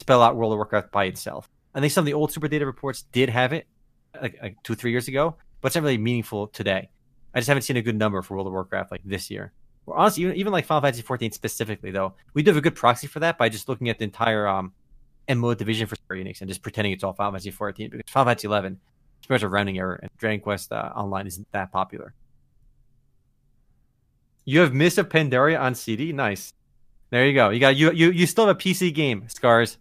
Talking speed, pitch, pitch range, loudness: 245 wpm, 120 Hz, 105-135 Hz, -23 LUFS